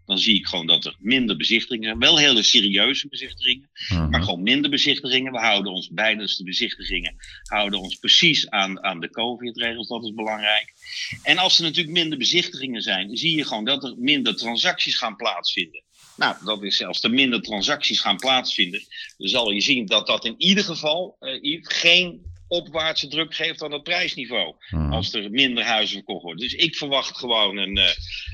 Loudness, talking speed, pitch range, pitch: -20 LUFS, 190 wpm, 100-160 Hz, 120 Hz